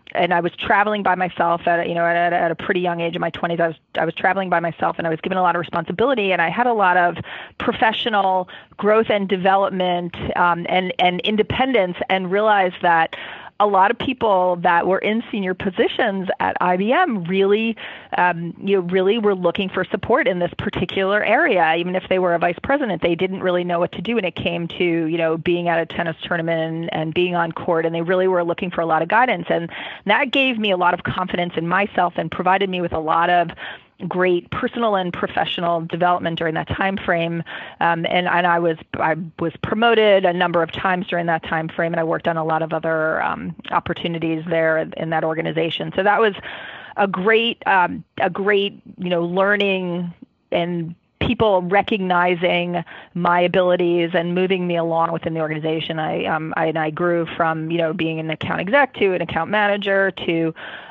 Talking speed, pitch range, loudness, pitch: 210 wpm, 170-195 Hz, -19 LUFS, 175 Hz